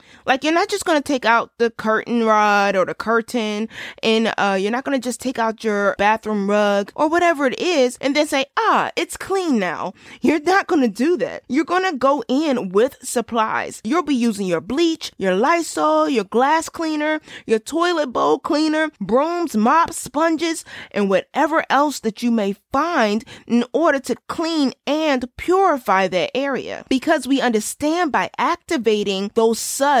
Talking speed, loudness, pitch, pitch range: 170 wpm, -19 LUFS, 265 Hz, 220-310 Hz